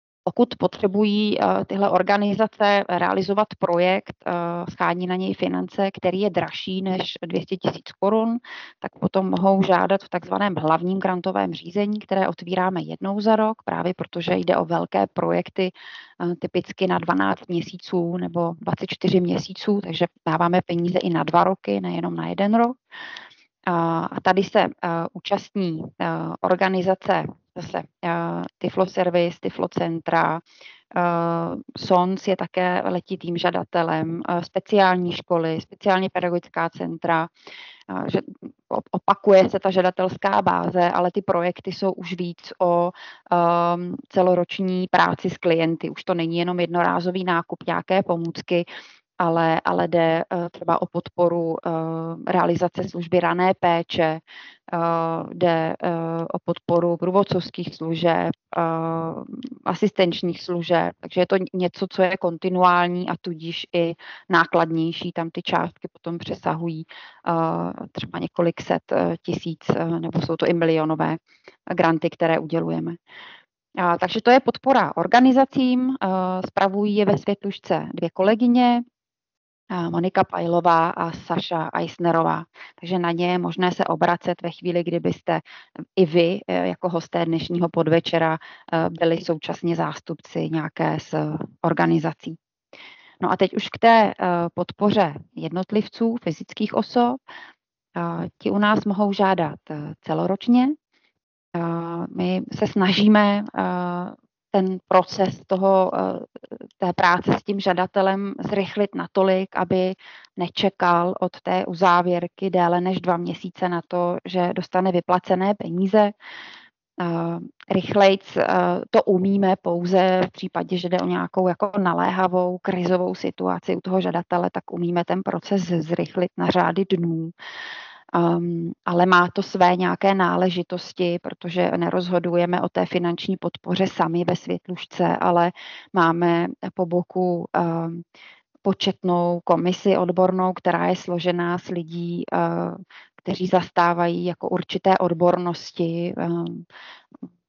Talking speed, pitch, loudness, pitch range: 125 wpm, 180 Hz, -22 LUFS, 170-190 Hz